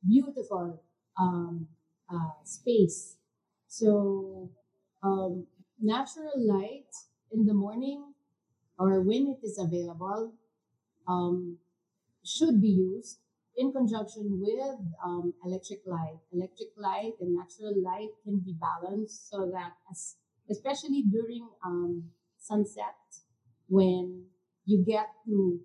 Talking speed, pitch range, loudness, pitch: 105 wpm, 175-215 Hz, -31 LUFS, 190 Hz